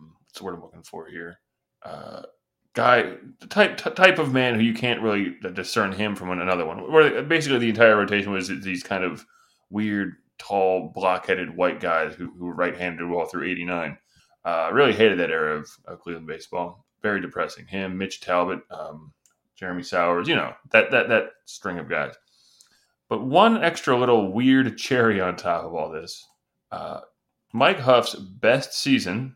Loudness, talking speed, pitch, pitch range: -22 LUFS, 175 wpm, 105 Hz, 90-125 Hz